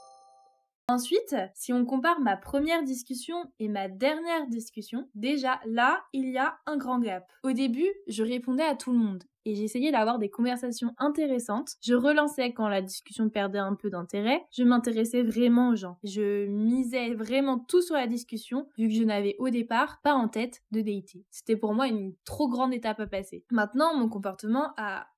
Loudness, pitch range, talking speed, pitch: -28 LUFS, 215-265 Hz, 185 wpm, 245 Hz